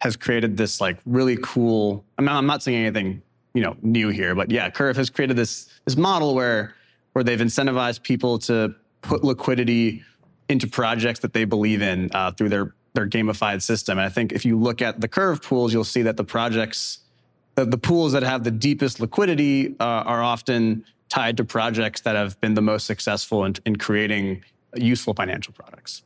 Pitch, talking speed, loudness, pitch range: 115 Hz, 195 wpm, -22 LUFS, 110-125 Hz